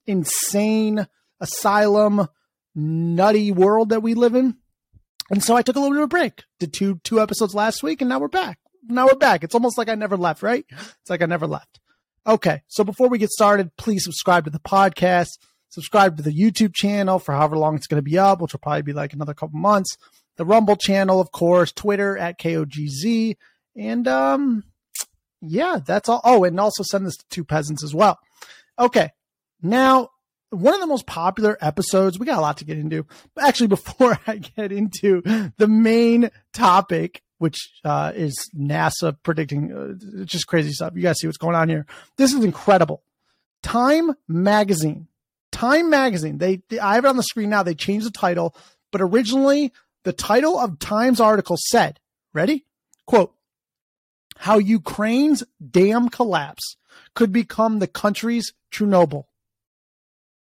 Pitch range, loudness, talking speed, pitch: 170-230 Hz, -19 LUFS, 180 wpm, 200 Hz